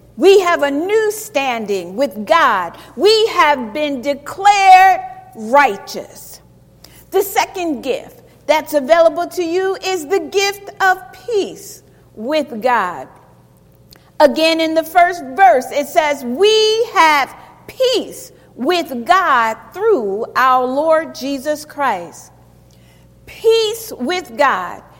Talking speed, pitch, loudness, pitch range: 110 wpm, 330 Hz, -15 LUFS, 280-390 Hz